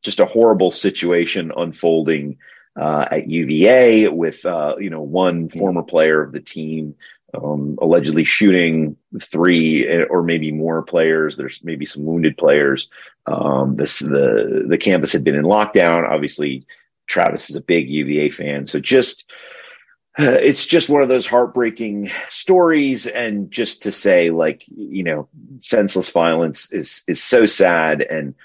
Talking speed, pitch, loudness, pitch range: 150 wpm, 85 Hz, -16 LUFS, 75-105 Hz